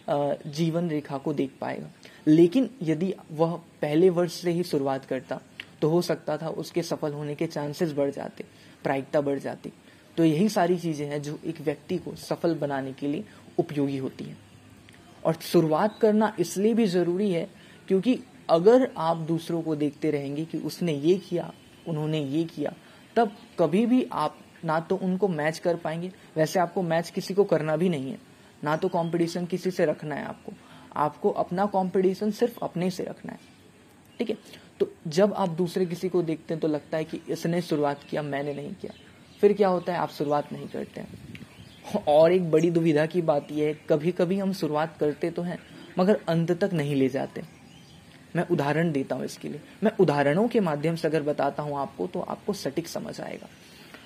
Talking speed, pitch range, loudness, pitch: 190 wpm, 150-185 Hz, -27 LUFS, 165 Hz